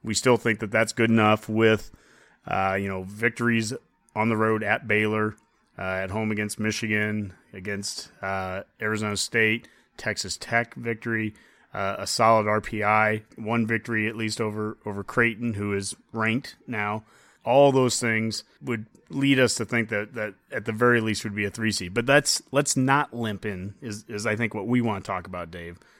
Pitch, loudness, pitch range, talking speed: 110 Hz, -25 LUFS, 105-115 Hz, 185 wpm